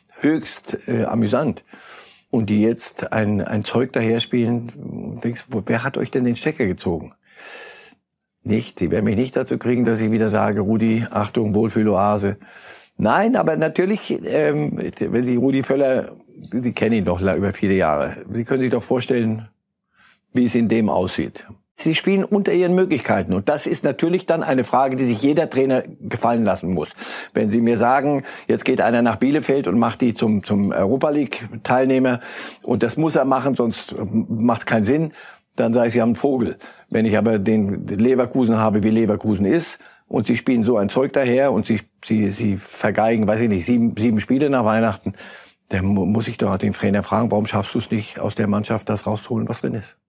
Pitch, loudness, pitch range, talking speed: 115 Hz, -20 LUFS, 110-130 Hz, 195 wpm